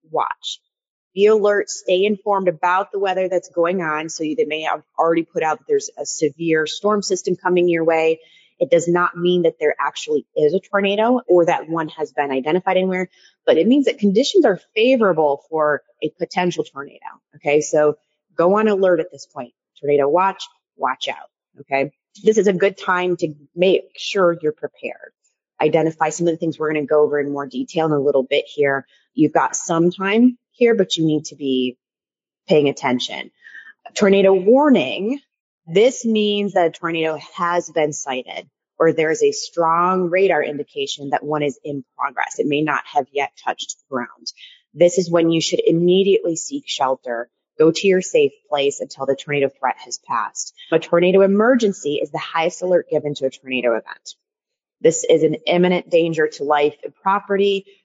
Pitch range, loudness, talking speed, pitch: 150-200 Hz, -19 LUFS, 185 wpm, 170 Hz